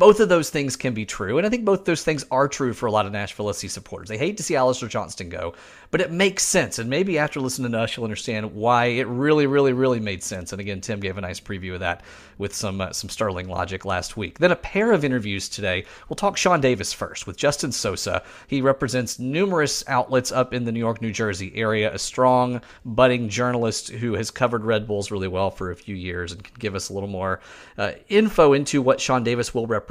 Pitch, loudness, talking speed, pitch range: 115 Hz, -23 LUFS, 245 wpm, 100-135 Hz